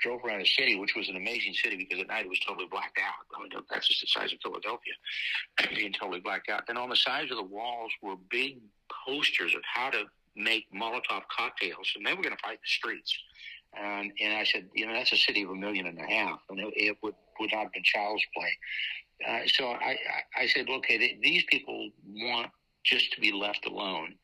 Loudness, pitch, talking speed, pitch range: -29 LUFS, 105 Hz, 230 wpm, 95-110 Hz